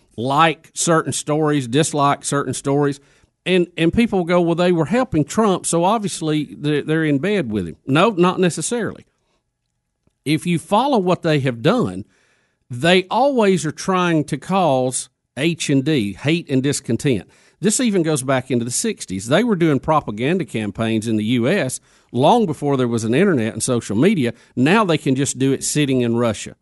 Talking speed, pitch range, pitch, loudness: 175 wpm, 130-175 Hz, 150 Hz, -18 LUFS